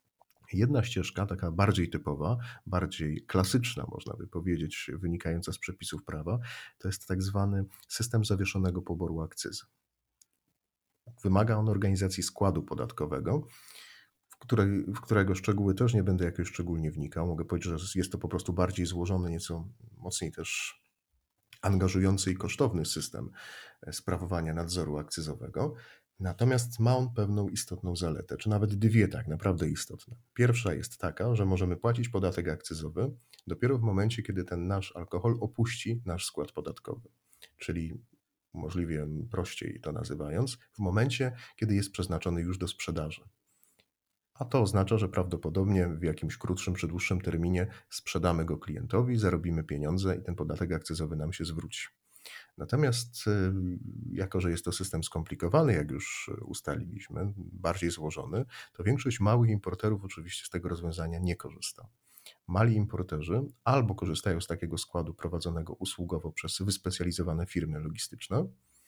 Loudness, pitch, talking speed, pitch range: -32 LUFS, 90 Hz, 140 wpm, 85-105 Hz